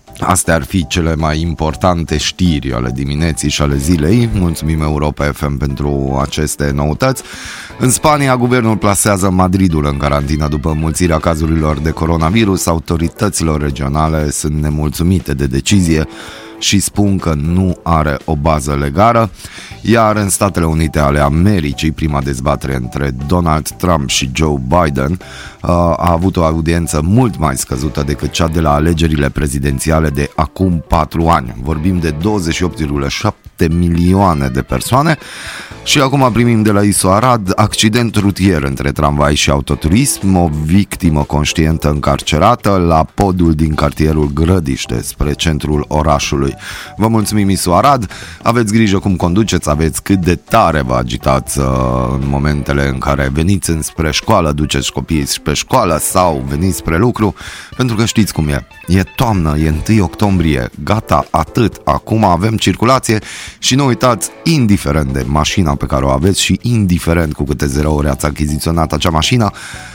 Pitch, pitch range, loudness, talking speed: 80 Hz, 75-95 Hz, -13 LUFS, 145 wpm